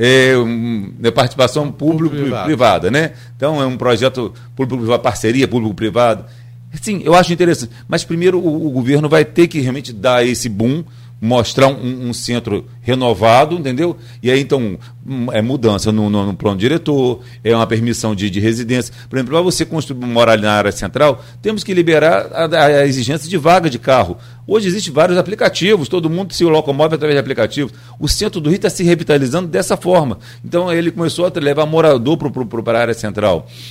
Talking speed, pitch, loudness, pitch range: 175 wpm, 130 Hz, -15 LUFS, 120-160 Hz